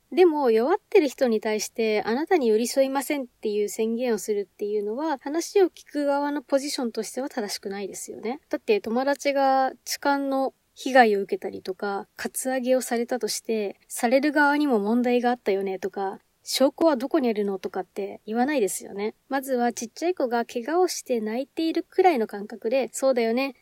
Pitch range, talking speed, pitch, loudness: 215-280 Hz, 405 characters per minute, 250 Hz, -25 LUFS